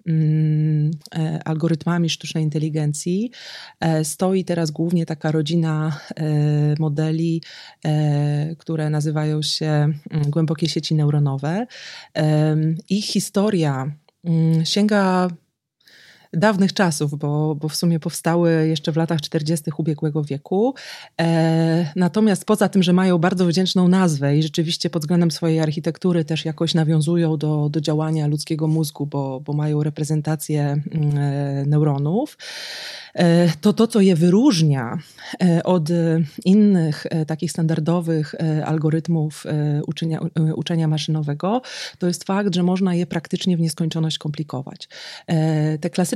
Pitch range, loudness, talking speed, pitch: 155-175 Hz, -20 LUFS, 120 wpm, 160 Hz